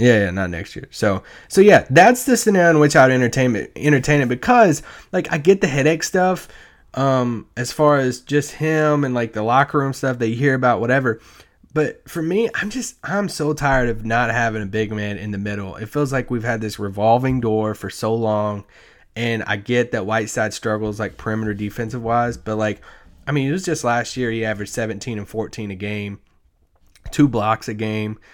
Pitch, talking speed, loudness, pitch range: 120 Hz, 210 wpm, -19 LUFS, 110-145 Hz